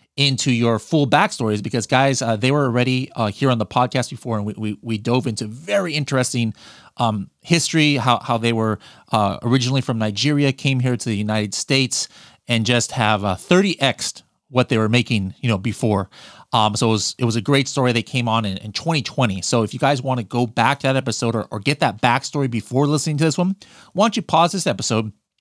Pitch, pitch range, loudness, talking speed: 125 Hz, 110-140 Hz, -19 LUFS, 220 wpm